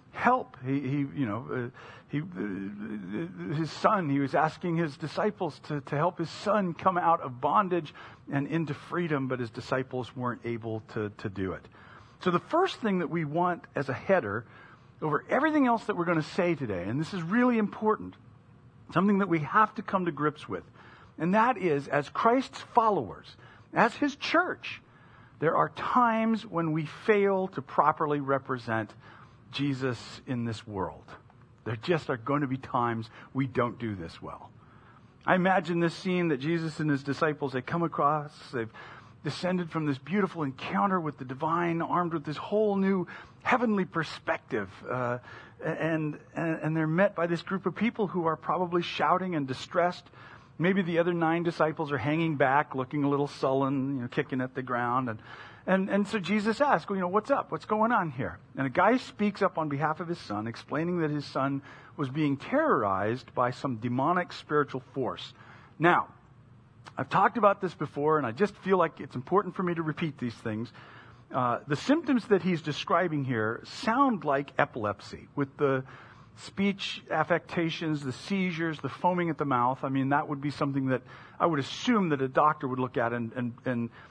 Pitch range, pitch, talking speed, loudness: 130-180 Hz, 150 Hz, 185 wpm, -29 LUFS